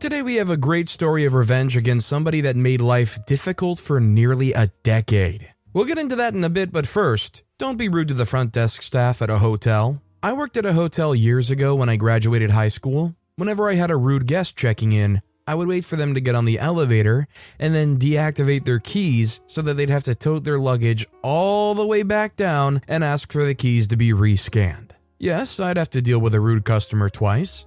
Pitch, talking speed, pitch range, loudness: 135 Hz, 230 wpm, 115-165 Hz, -20 LUFS